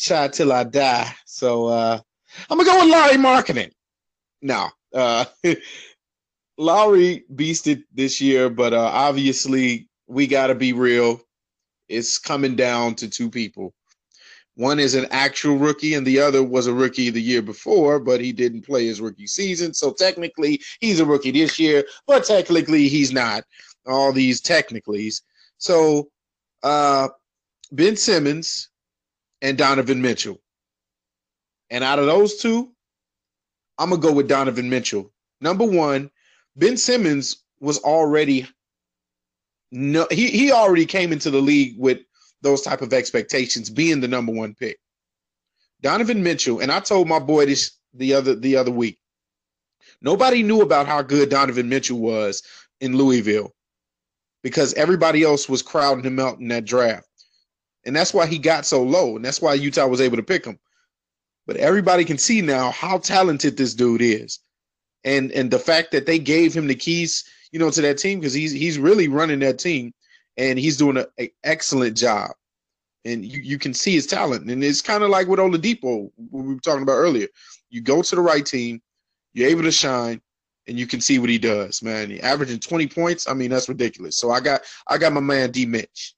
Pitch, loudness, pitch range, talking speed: 135 Hz, -19 LUFS, 125-160 Hz, 175 wpm